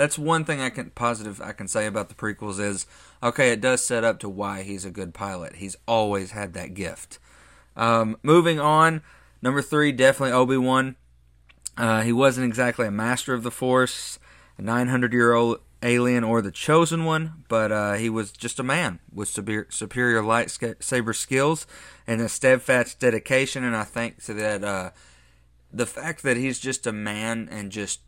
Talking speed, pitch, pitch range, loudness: 185 wpm, 115 Hz, 105-130 Hz, -23 LUFS